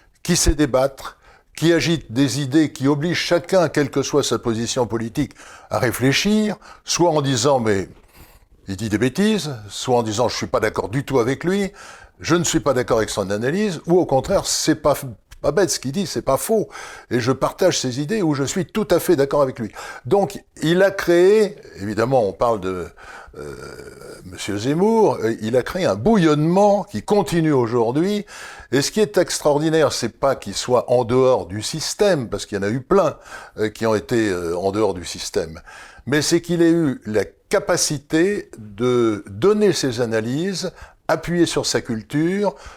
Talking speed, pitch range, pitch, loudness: 185 wpm, 120-175 Hz, 145 Hz, -19 LUFS